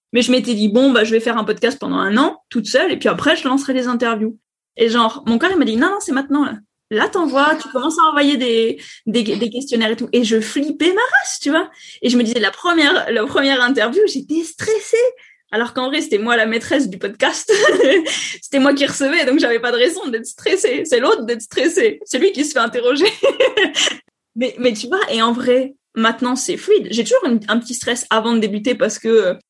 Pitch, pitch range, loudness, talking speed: 260 Hz, 235-325 Hz, -16 LUFS, 240 wpm